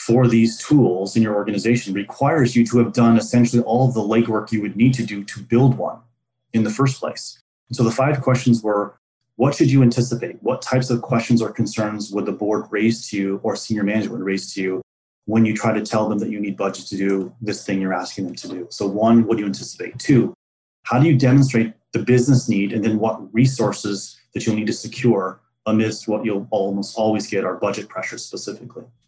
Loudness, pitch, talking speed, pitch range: -20 LUFS, 110 Hz, 225 wpm, 105-120 Hz